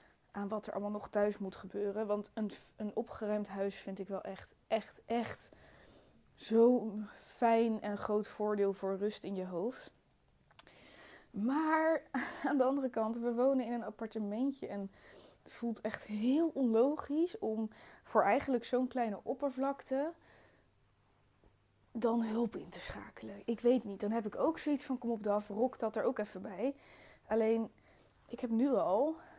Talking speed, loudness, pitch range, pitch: 160 wpm, -36 LUFS, 210-255 Hz, 225 Hz